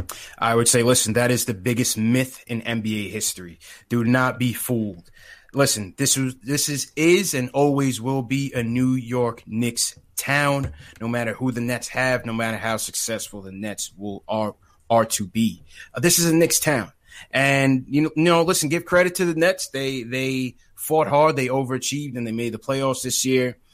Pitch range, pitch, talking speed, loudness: 115-135 Hz, 125 Hz, 195 wpm, -21 LUFS